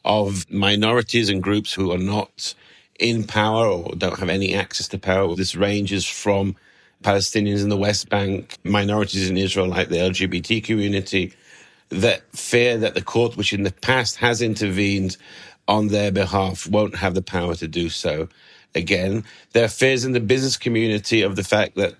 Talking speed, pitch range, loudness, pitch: 175 wpm, 95-110 Hz, -21 LUFS, 100 Hz